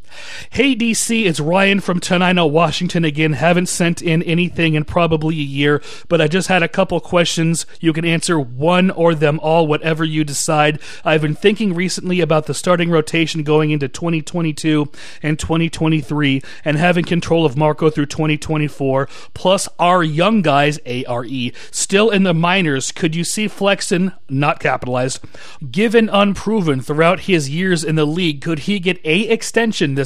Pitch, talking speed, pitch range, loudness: 165 Hz, 165 wpm, 150-180 Hz, -16 LUFS